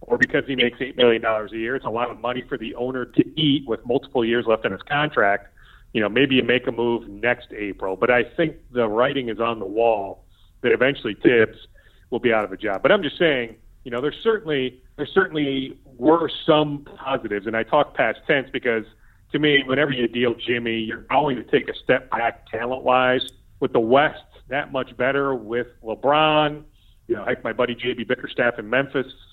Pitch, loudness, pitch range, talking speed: 120 Hz, -22 LUFS, 115-135 Hz, 210 wpm